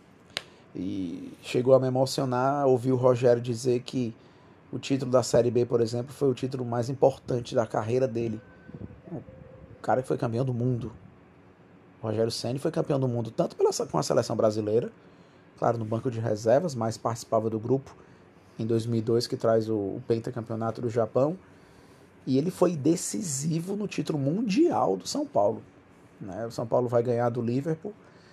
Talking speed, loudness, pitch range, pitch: 170 wpm, -27 LUFS, 115-135 Hz, 120 Hz